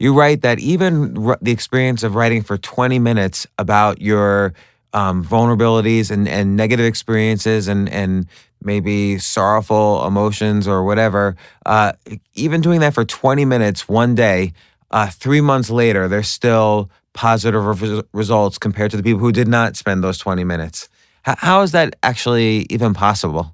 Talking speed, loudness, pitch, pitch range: 160 wpm, -16 LUFS, 110 Hz, 100-120 Hz